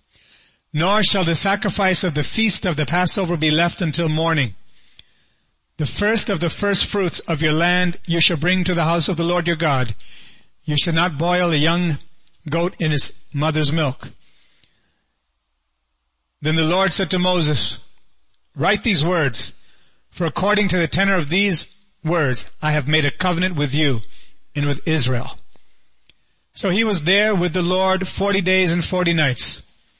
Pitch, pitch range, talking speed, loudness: 170 Hz, 150-185 Hz, 170 wpm, -17 LUFS